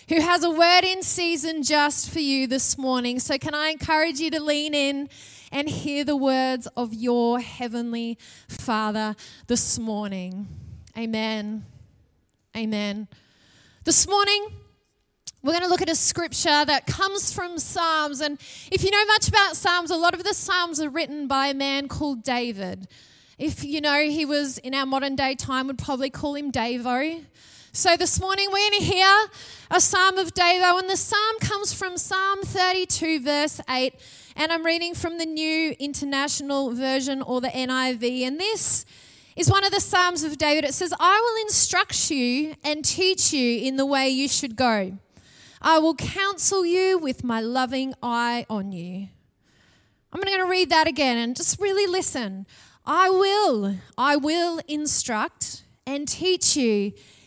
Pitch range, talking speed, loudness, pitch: 255-350 Hz, 170 wpm, -21 LUFS, 295 Hz